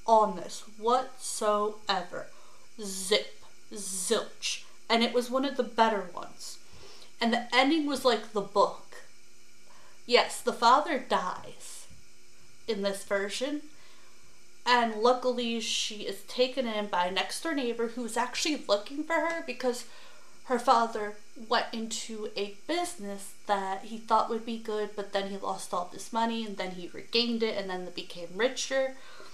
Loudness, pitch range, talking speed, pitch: -30 LUFS, 205-250 Hz, 150 wpm, 230 Hz